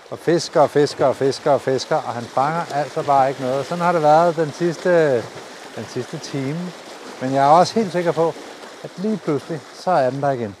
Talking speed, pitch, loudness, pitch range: 220 wpm, 150 Hz, -19 LUFS, 135-170 Hz